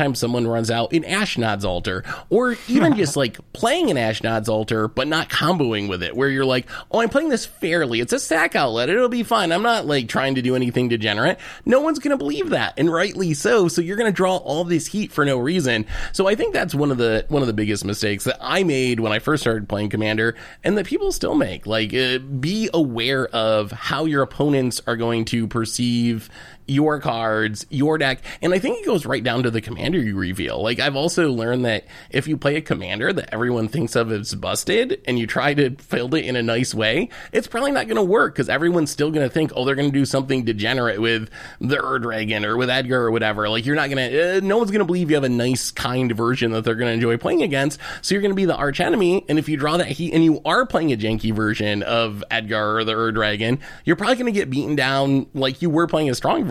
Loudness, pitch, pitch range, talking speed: -20 LUFS, 130 Hz, 115-160 Hz, 245 wpm